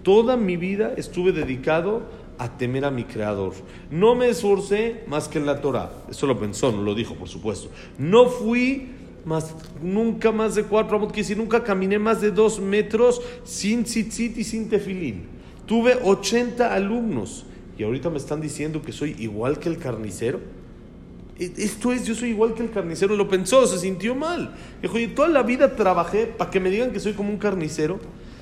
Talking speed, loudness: 190 wpm, -23 LUFS